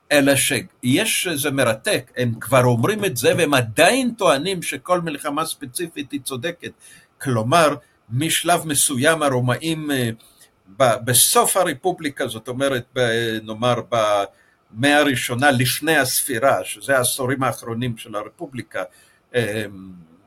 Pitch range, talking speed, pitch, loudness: 120-150 Hz, 105 wpm, 130 Hz, -19 LUFS